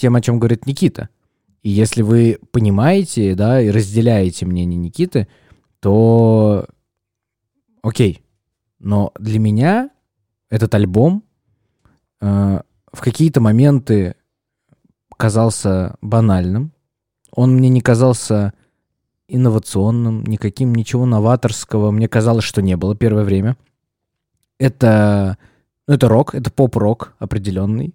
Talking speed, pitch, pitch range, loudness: 105 wpm, 110 Hz, 105-125 Hz, -15 LUFS